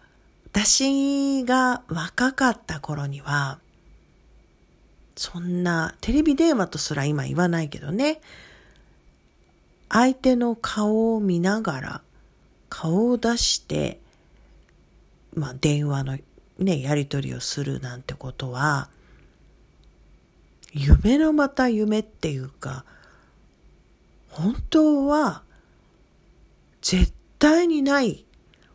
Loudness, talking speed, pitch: -23 LUFS, 165 characters per minute, 175 Hz